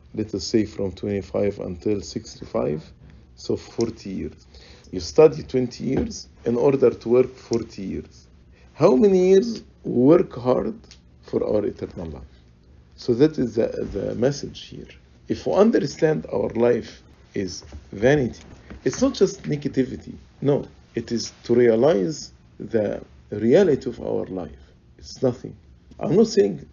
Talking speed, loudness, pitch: 140 wpm, -22 LUFS, 100 Hz